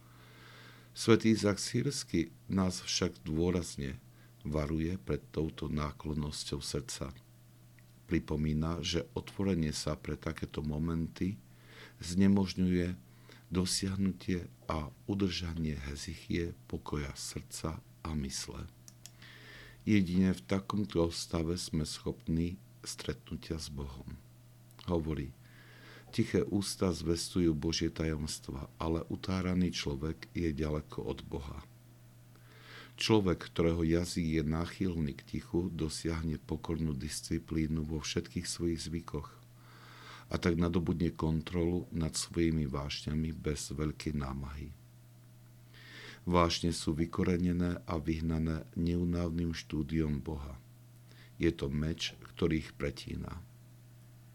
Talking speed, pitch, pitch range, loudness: 95 wpm, 80 Hz, 75-90 Hz, -35 LUFS